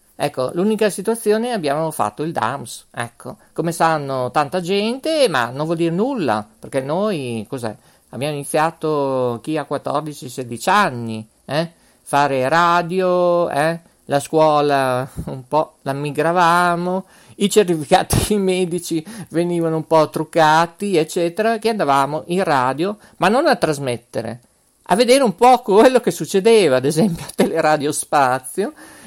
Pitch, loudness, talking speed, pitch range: 160 Hz, -18 LUFS, 135 wpm, 140-195 Hz